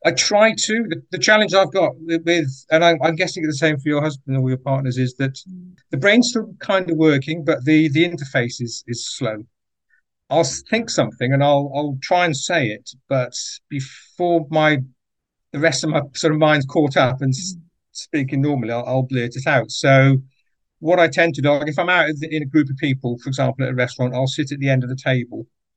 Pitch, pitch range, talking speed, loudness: 145 Hz, 130-165 Hz, 215 wpm, -19 LUFS